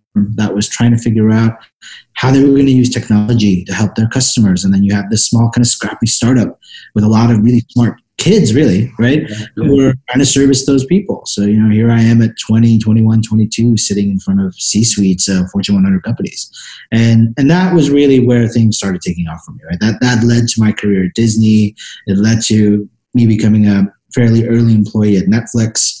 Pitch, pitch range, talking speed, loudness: 110 Hz, 105-120 Hz, 220 wpm, -11 LUFS